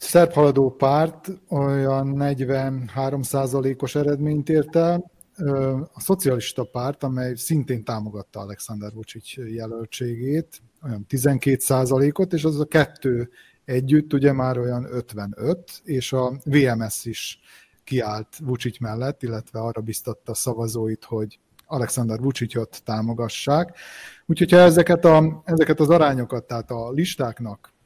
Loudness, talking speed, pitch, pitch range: -22 LUFS, 120 wpm, 135 Hz, 115-150 Hz